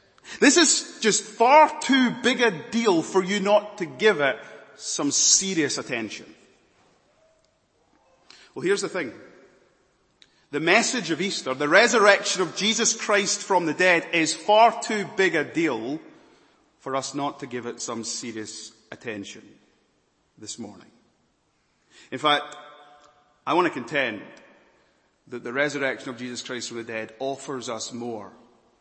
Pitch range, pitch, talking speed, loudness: 135-225 Hz, 180 Hz, 140 wpm, -22 LUFS